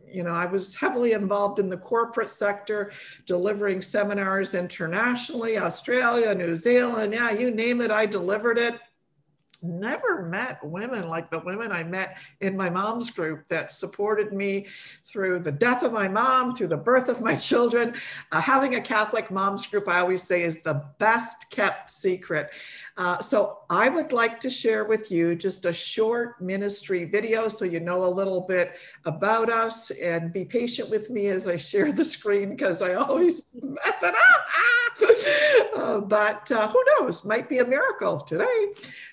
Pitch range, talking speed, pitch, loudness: 185-240 Hz, 170 wpm, 210 Hz, -24 LUFS